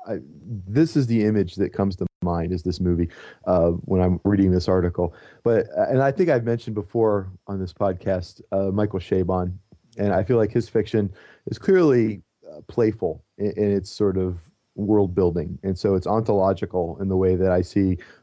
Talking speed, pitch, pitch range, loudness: 190 wpm, 95 Hz, 90-105 Hz, -23 LUFS